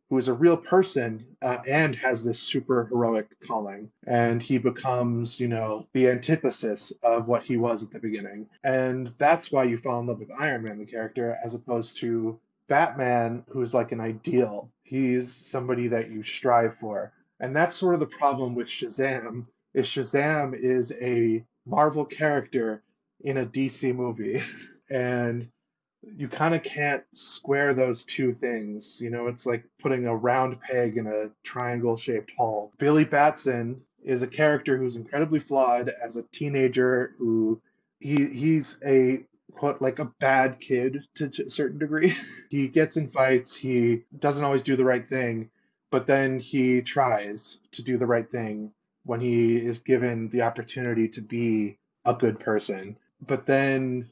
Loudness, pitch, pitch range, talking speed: -26 LUFS, 125 Hz, 115-135 Hz, 170 wpm